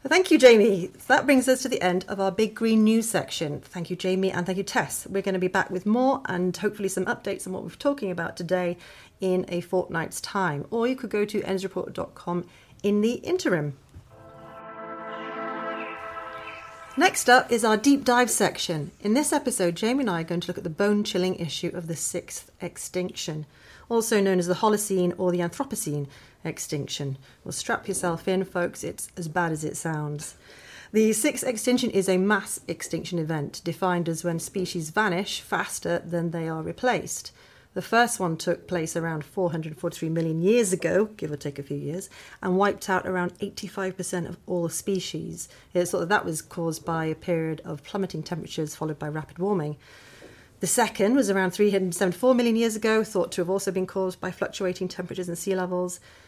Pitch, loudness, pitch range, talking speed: 185 Hz, -26 LUFS, 170-210 Hz, 190 wpm